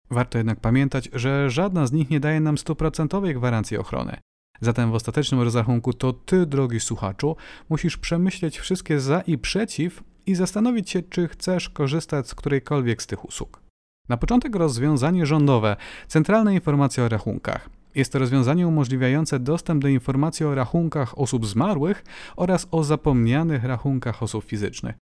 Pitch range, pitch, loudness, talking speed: 125-165 Hz, 145 Hz, -23 LUFS, 150 wpm